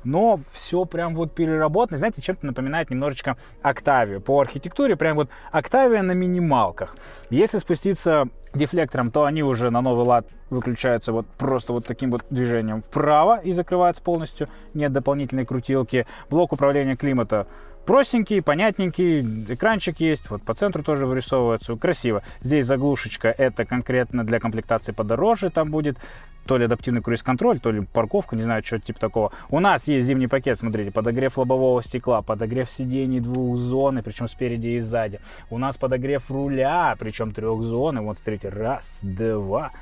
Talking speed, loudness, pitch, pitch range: 155 wpm, -22 LUFS, 130 Hz, 115-155 Hz